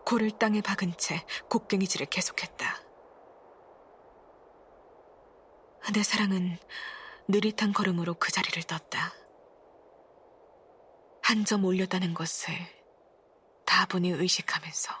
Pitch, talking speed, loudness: 205 Hz, 195 characters per minute, -29 LUFS